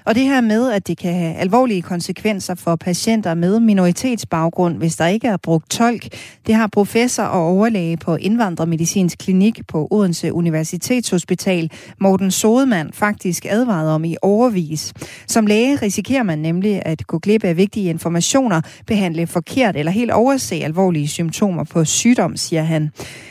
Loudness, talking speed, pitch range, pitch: -17 LUFS, 155 wpm, 165-220 Hz, 185 Hz